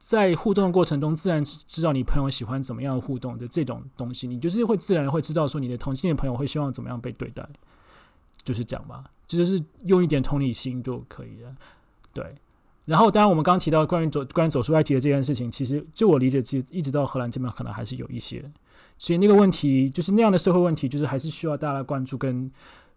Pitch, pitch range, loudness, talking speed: 145 Hz, 130-170 Hz, -24 LUFS, 375 characters per minute